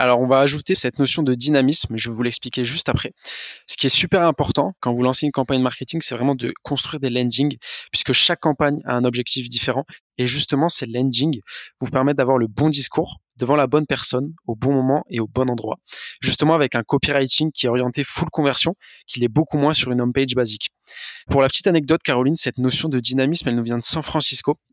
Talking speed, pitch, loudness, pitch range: 225 wpm, 135 Hz, -18 LUFS, 125-150 Hz